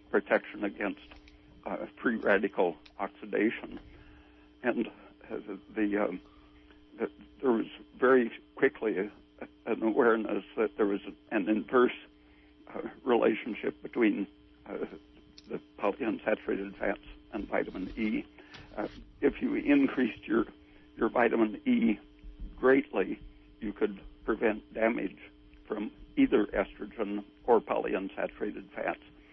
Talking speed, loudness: 110 wpm, -31 LUFS